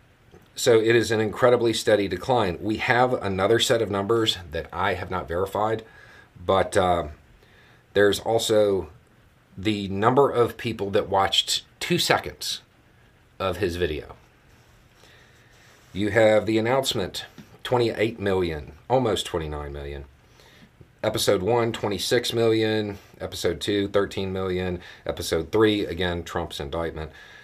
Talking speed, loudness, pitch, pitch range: 120 wpm, -24 LUFS, 105 Hz, 90-115 Hz